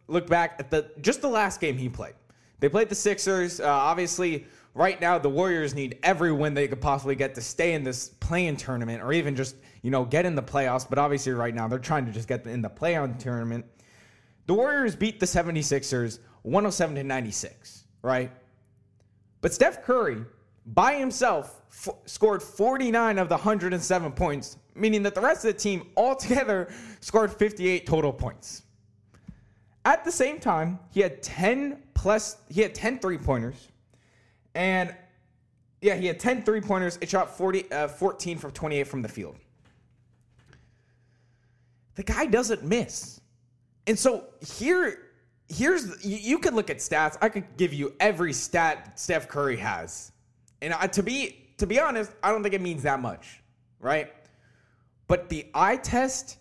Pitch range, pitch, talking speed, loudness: 120-200 Hz, 150 Hz, 170 wpm, -26 LUFS